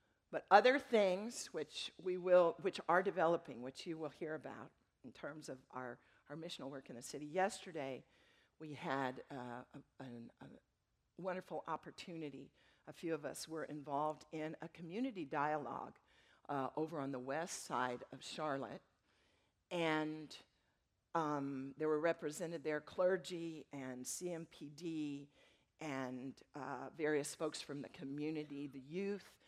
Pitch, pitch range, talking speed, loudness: 155 Hz, 140-170 Hz, 140 wpm, -41 LUFS